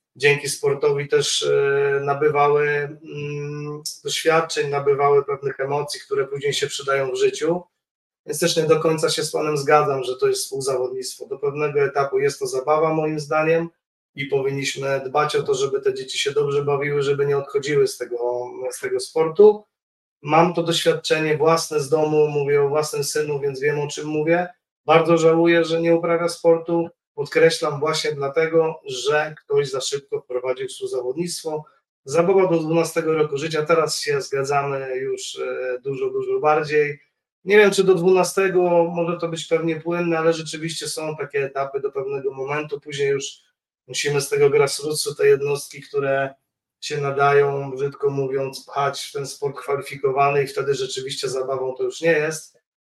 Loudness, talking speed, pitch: -21 LUFS, 160 wpm, 160 Hz